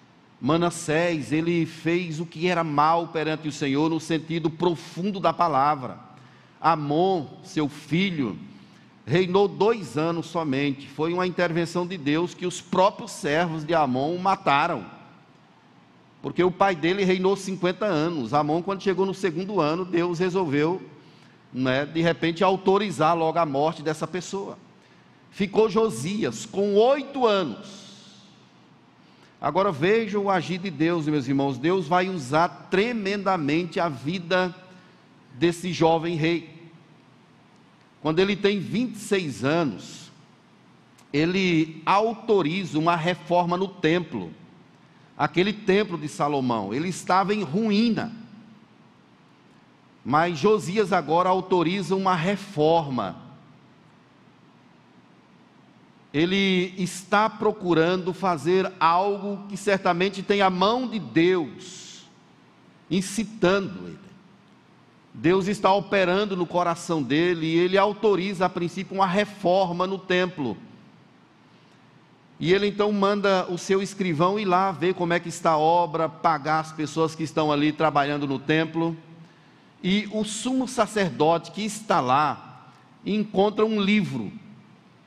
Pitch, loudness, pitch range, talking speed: 180 Hz, -24 LUFS, 160-195 Hz, 120 wpm